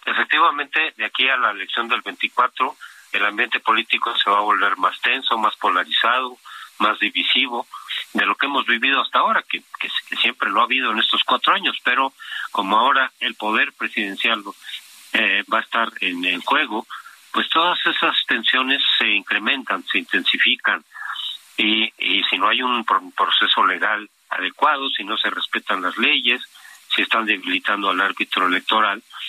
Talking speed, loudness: 165 wpm, -19 LUFS